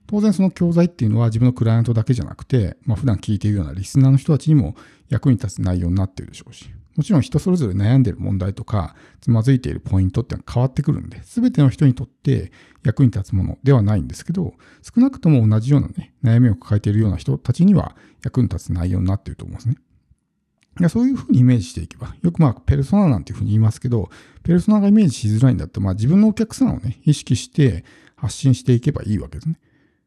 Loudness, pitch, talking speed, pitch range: -18 LUFS, 125 Hz, 525 characters per minute, 105-145 Hz